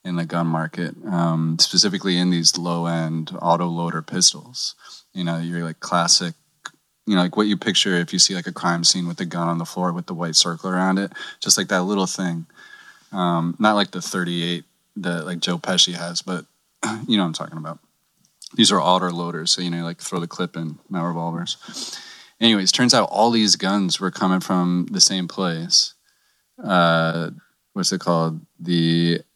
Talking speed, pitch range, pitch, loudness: 195 wpm, 85-90 Hz, 85 Hz, -20 LUFS